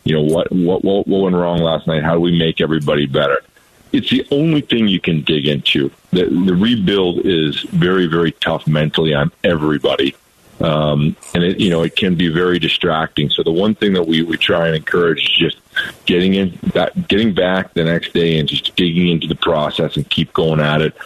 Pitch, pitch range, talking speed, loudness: 85 Hz, 80-90 Hz, 210 wpm, -15 LUFS